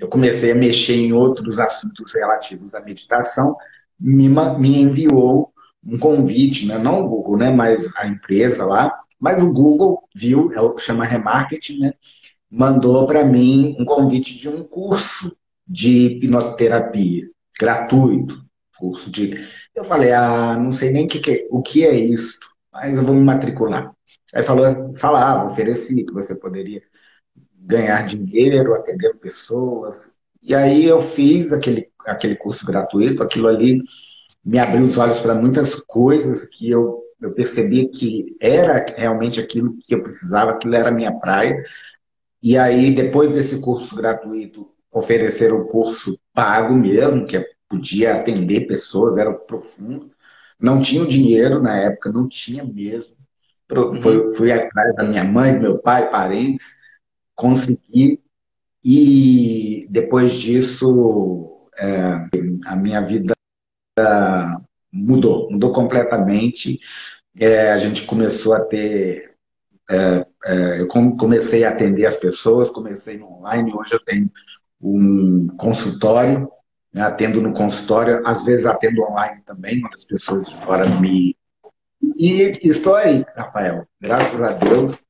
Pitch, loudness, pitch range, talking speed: 120 Hz, -16 LUFS, 110-135 Hz, 140 wpm